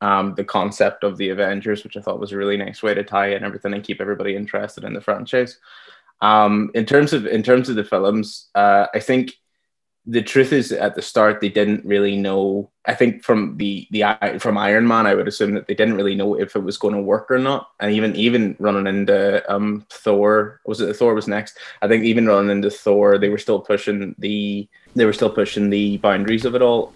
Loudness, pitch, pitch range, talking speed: -19 LUFS, 105 Hz, 100-110 Hz, 230 wpm